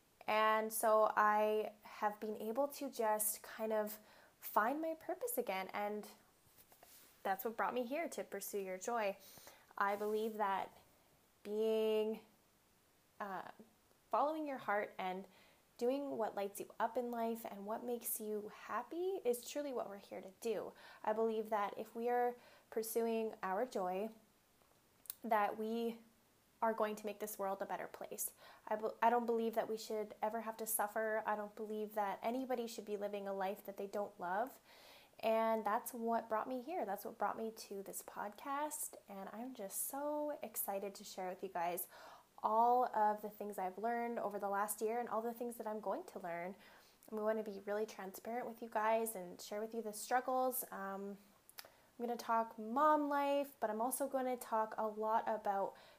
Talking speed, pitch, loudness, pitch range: 185 wpm, 220 Hz, -40 LUFS, 205-235 Hz